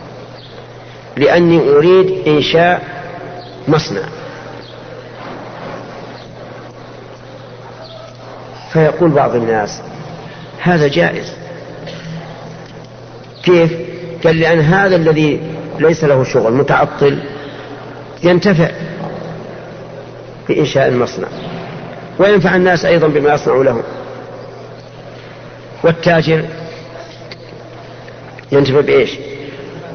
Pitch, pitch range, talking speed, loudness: 160 Hz, 140-175 Hz, 60 wpm, -12 LUFS